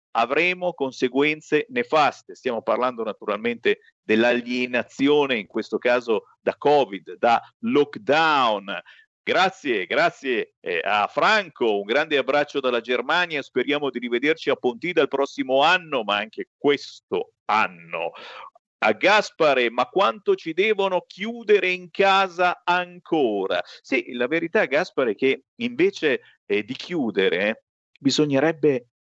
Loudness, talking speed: -22 LUFS, 120 wpm